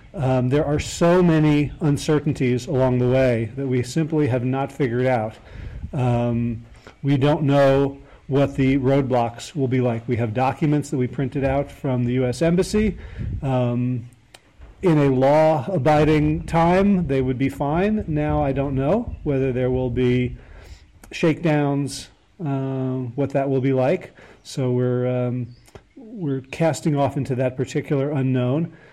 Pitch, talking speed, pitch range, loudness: 135 Hz, 150 wpm, 125-150 Hz, -21 LUFS